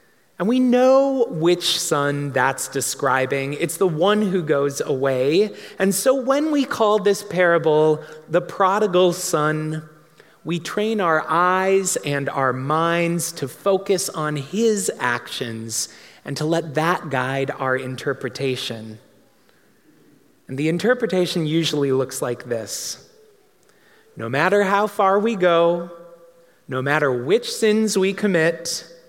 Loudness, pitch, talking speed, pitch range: -20 LUFS, 170 Hz, 125 wpm, 145-200 Hz